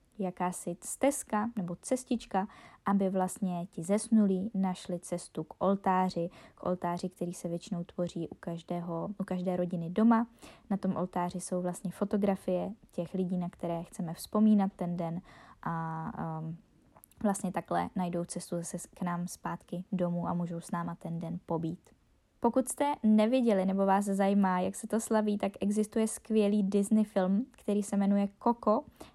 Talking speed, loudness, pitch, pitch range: 155 wpm, -32 LUFS, 185 Hz, 175-210 Hz